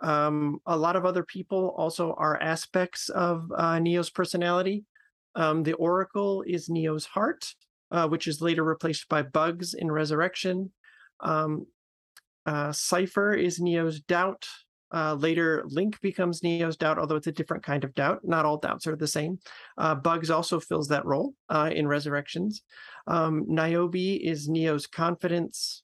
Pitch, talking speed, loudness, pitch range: 165 Hz, 155 wpm, -28 LUFS, 155-180 Hz